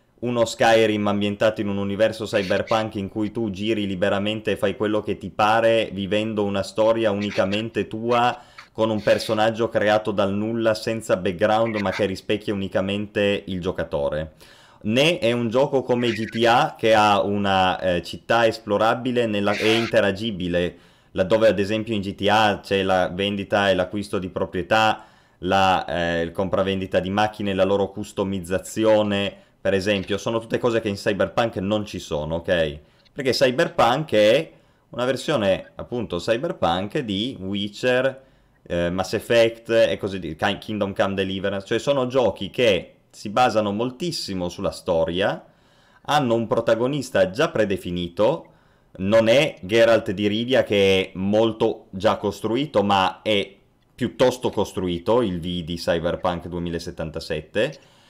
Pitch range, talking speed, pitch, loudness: 95-115 Hz, 140 wpm, 105 Hz, -22 LUFS